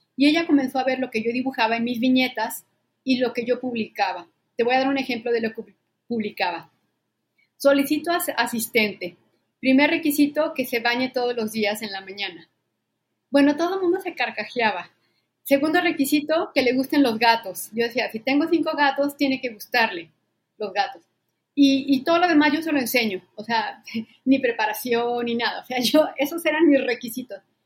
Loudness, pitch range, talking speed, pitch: -22 LUFS, 225-285 Hz, 190 wpm, 255 Hz